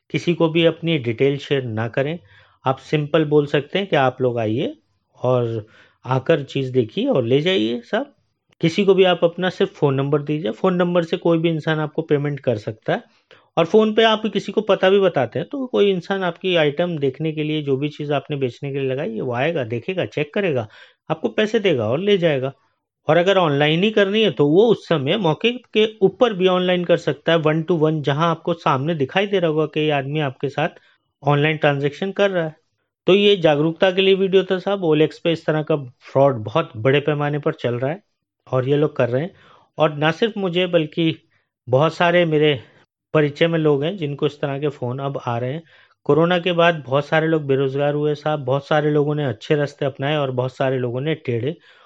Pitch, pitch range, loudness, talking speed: 155 Hz, 140-175 Hz, -19 LUFS, 215 wpm